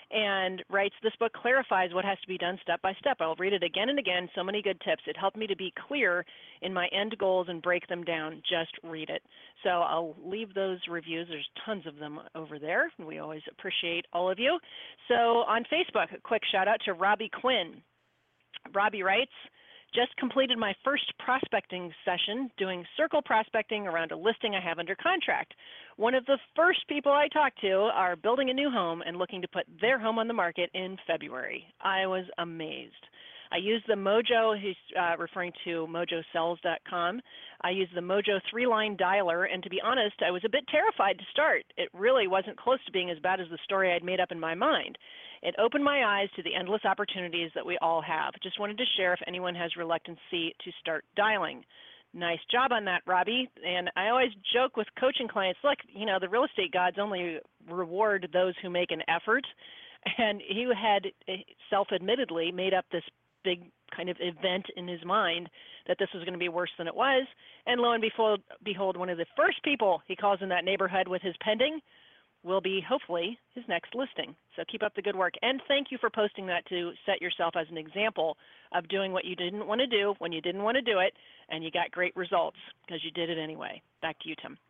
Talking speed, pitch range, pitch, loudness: 215 wpm, 175-230 Hz, 195 Hz, -30 LUFS